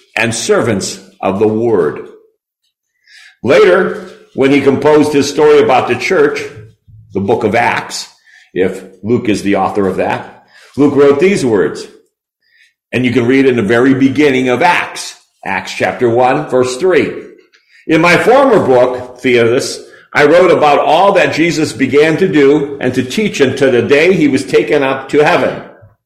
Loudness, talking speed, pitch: -11 LUFS, 160 wpm, 140 Hz